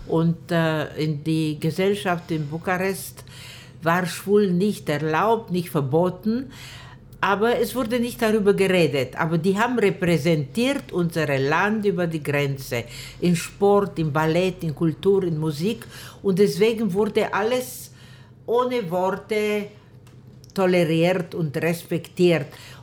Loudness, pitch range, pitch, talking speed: -22 LUFS, 150-200 Hz, 170 Hz, 115 wpm